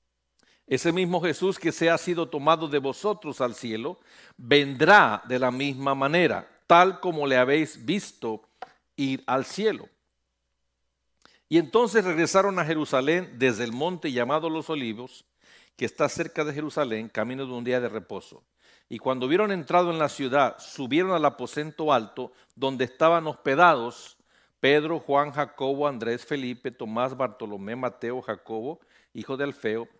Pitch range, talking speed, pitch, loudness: 120-165 Hz, 145 wpm, 140 Hz, -25 LUFS